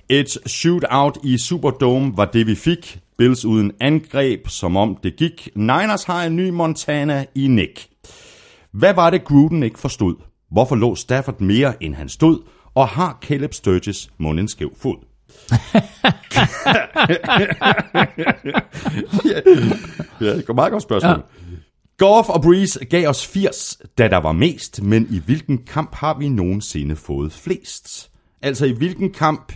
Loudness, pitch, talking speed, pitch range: -17 LUFS, 135 Hz, 140 wpm, 105-160 Hz